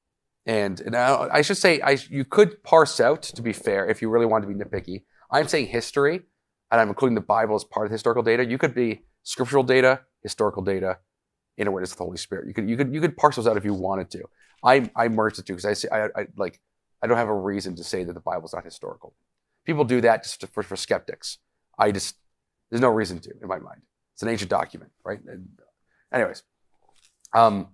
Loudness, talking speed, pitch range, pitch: -23 LUFS, 235 wpm, 100-135 Hz, 115 Hz